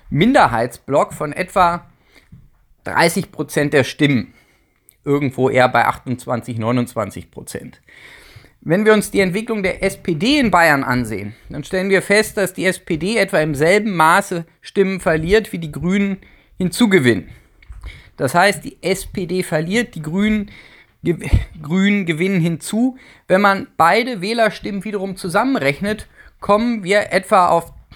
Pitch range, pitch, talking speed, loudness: 150-200 Hz, 185 Hz, 125 wpm, -17 LUFS